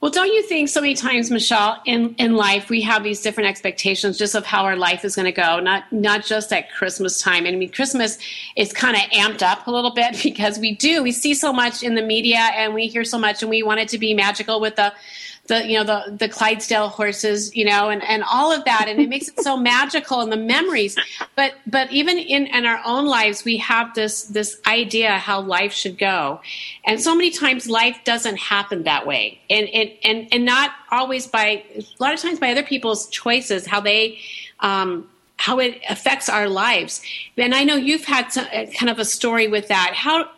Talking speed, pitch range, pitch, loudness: 225 wpm, 210-255 Hz, 220 Hz, -18 LUFS